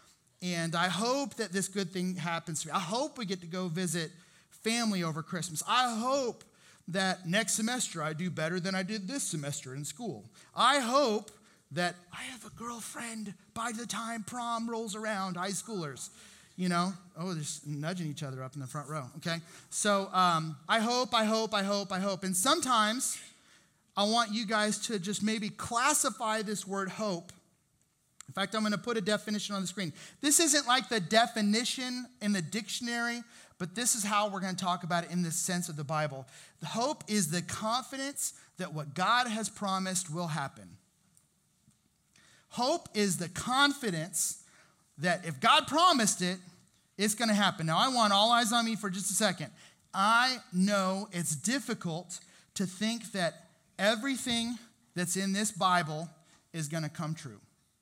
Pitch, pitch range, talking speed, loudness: 195 Hz, 170-225 Hz, 180 wpm, -31 LUFS